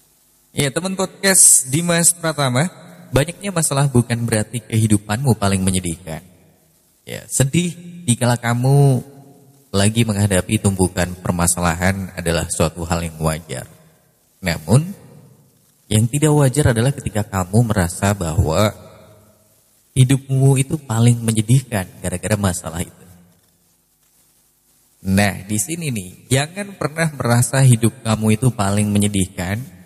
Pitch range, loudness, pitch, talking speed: 95-140 Hz, -17 LUFS, 110 Hz, 105 wpm